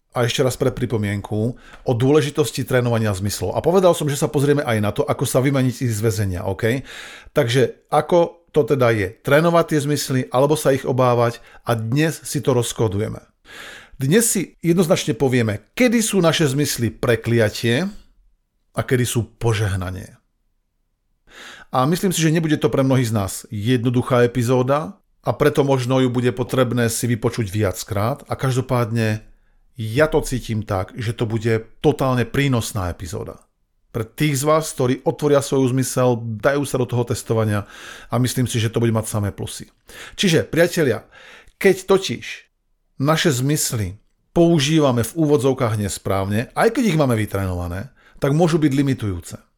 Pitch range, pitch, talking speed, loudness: 115-145 Hz, 125 Hz, 155 wpm, -19 LUFS